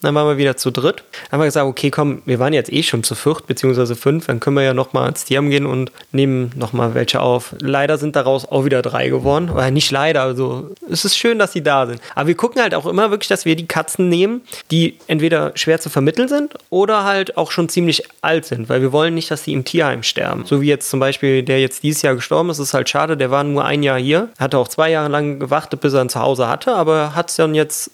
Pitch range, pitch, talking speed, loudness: 135-165 Hz, 145 Hz, 265 wpm, -16 LUFS